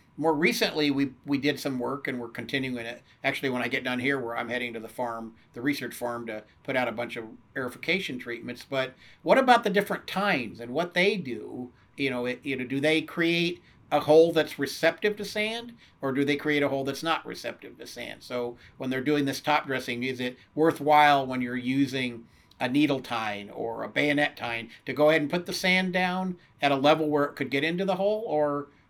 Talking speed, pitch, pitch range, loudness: 225 wpm, 140 Hz, 125-155 Hz, -27 LUFS